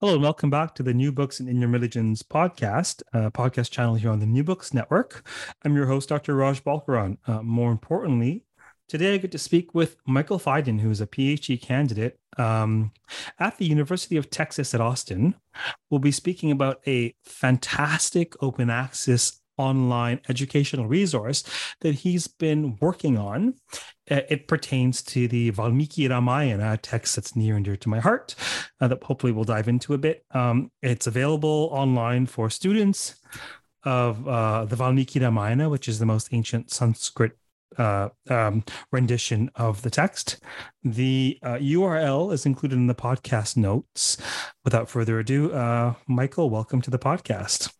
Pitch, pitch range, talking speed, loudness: 130 Hz, 120-145 Hz, 165 wpm, -24 LUFS